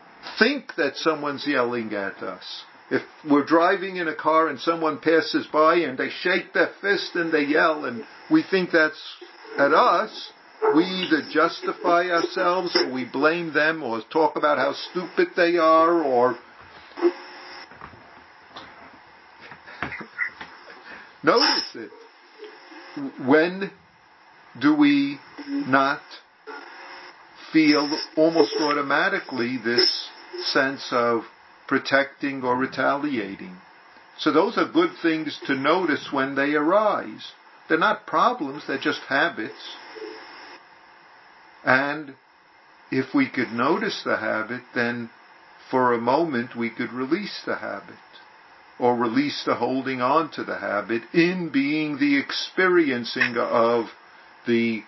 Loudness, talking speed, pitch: -22 LUFS, 115 wpm, 160 Hz